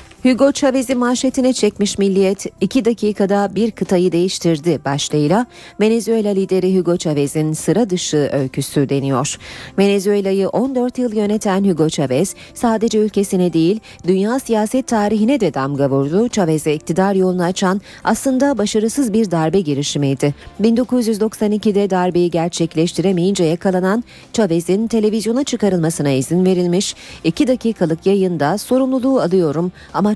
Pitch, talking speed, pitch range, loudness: 195 Hz, 115 wpm, 165-220 Hz, -16 LUFS